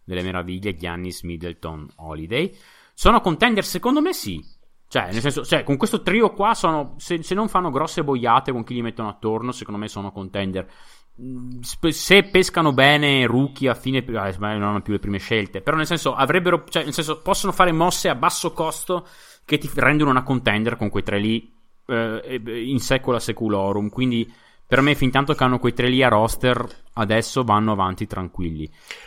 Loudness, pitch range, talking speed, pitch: -21 LUFS, 105-155 Hz, 185 wpm, 125 Hz